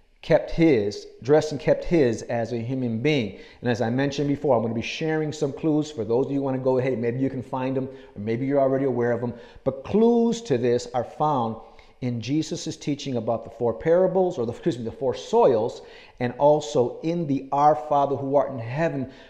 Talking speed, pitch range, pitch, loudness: 225 wpm, 120-155 Hz, 135 Hz, -24 LUFS